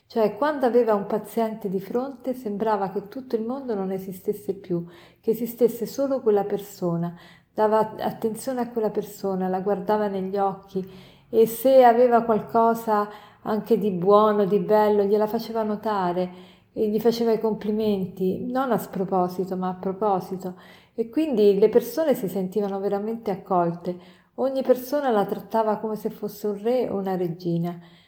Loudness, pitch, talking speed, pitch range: -24 LUFS, 210 Hz, 155 wpm, 195-225 Hz